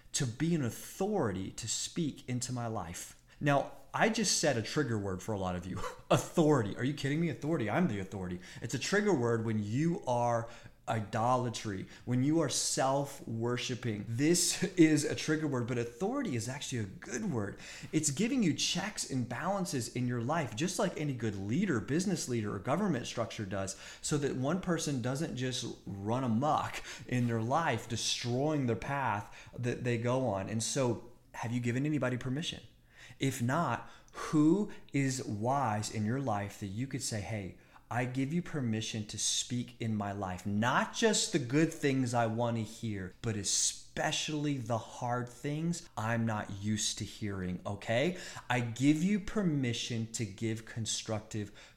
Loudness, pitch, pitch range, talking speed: -33 LUFS, 125 Hz, 110-150 Hz, 175 wpm